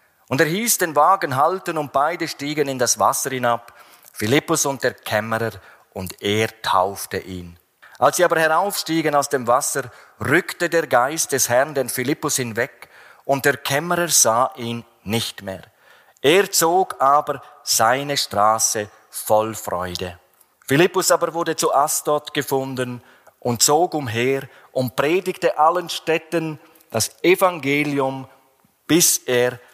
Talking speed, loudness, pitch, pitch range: 135 wpm, -19 LUFS, 140 Hz, 120-160 Hz